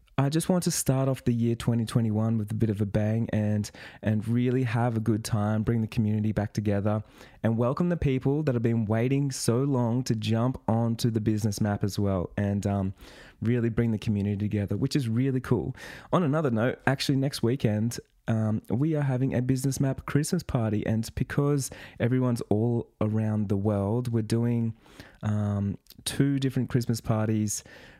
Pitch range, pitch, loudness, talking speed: 105-130 Hz, 115 Hz, -27 LUFS, 180 wpm